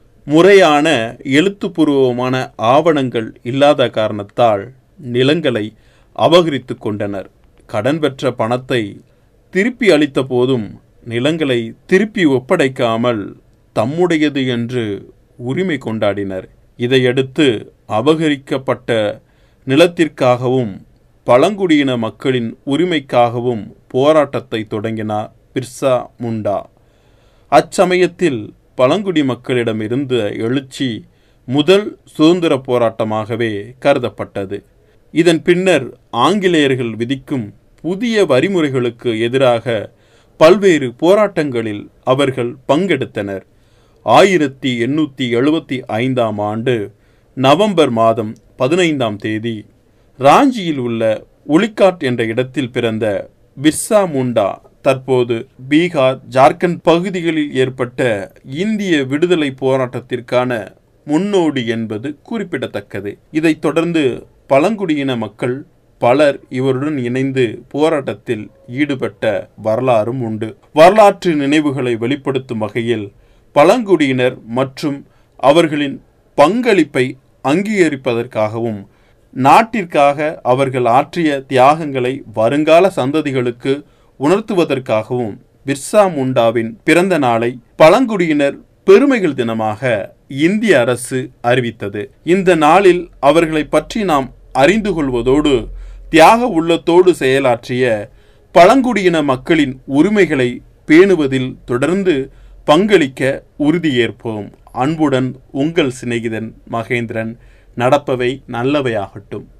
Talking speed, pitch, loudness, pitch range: 75 wpm, 130 Hz, -14 LUFS, 115-155 Hz